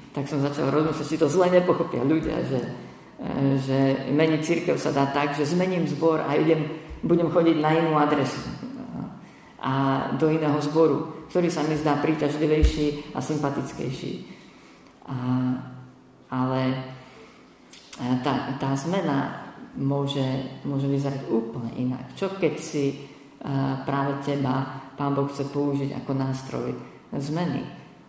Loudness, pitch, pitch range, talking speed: -25 LUFS, 140 Hz, 135-155 Hz, 130 wpm